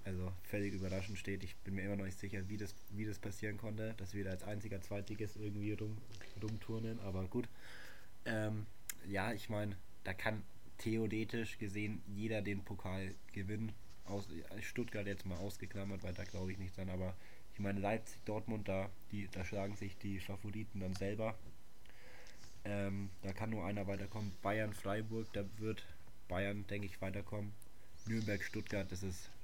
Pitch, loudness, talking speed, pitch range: 100 Hz, -44 LUFS, 170 wpm, 95-110 Hz